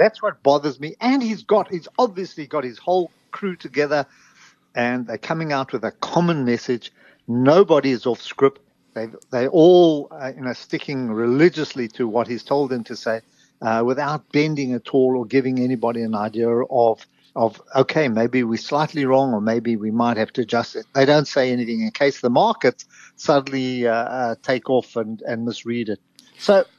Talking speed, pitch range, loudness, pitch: 190 wpm, 120-150 Hz, -20 LUFS, 130 Hz